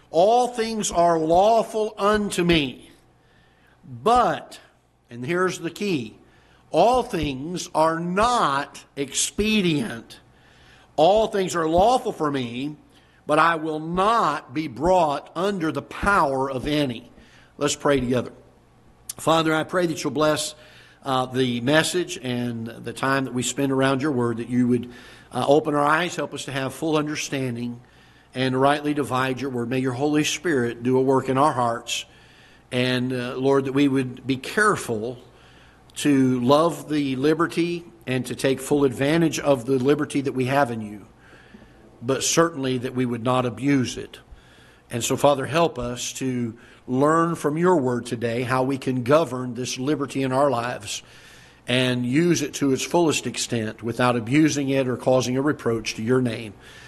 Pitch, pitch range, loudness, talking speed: 140 Hz, 125-155 Hz, -22 LUFS, 160 wpm